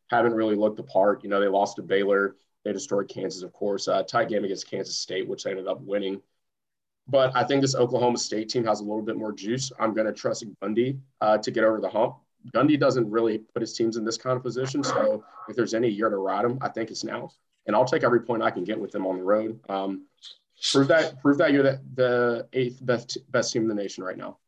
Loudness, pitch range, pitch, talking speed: -25 LUFS, 105-130 Hz, 115 Hz, 255 wpm